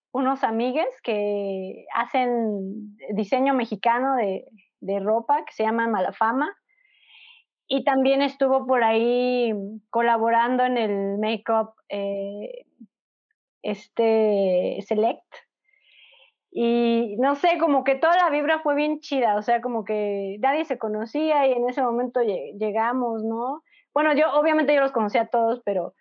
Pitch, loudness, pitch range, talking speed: 240 Hz, -23 LUFS, 220-285 Hz, 135 wpm